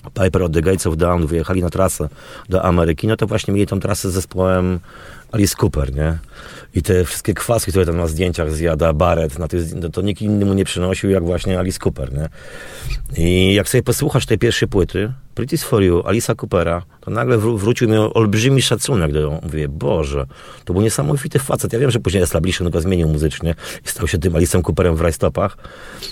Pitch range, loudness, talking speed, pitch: 85-110 Hz, -18 LUFS, 205 wpm, 95 Hz